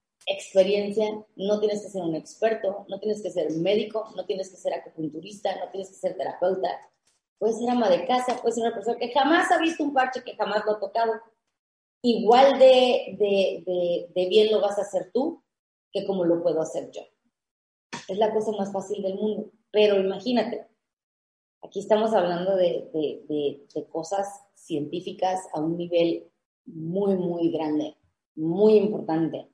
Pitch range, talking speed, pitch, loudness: 180-220 Hz, 175 wpm, 200 Hz, -25 LUFS